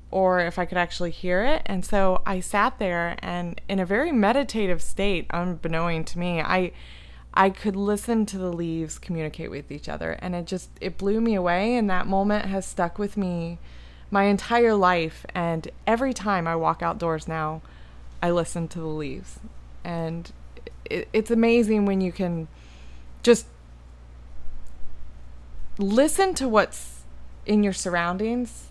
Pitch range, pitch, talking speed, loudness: 160-200 Hz, 175 Hz, 155 wpm, -25 LUFS